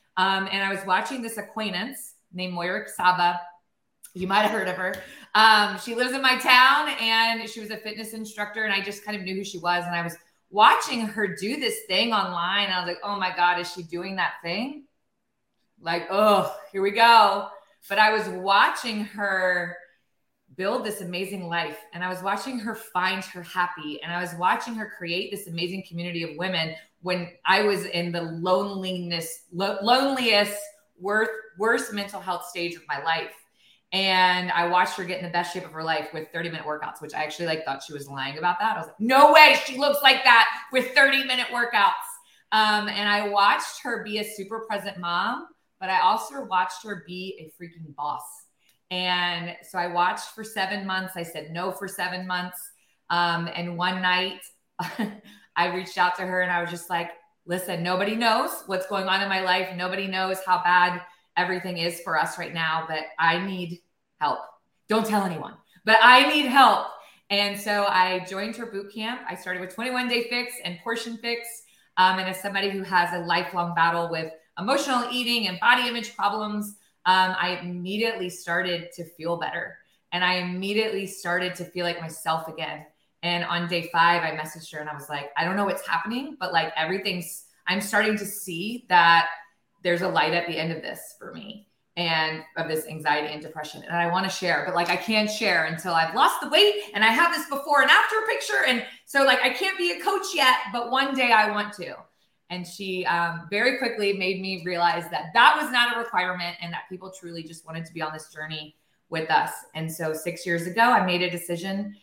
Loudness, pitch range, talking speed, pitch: -23 LUFS, 175-215 Hz, 205 wpm, 185 Hz